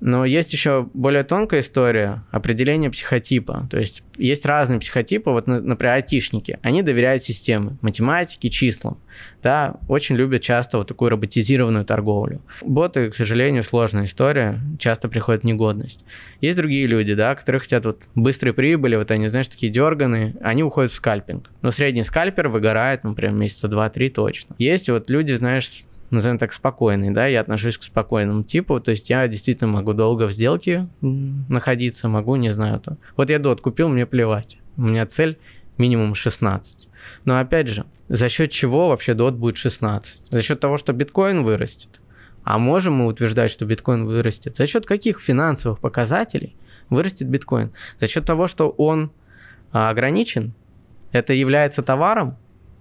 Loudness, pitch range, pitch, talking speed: -20 LUFS, 110-140 Hz, 125 Hz, 160 wpm